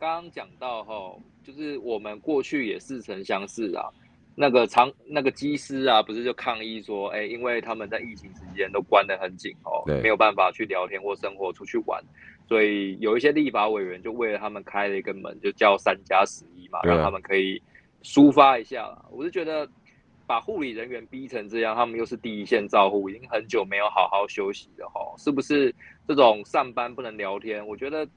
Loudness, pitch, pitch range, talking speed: -25 LUFS, 115 Hz, 105-145 Hz, 300 characters per minute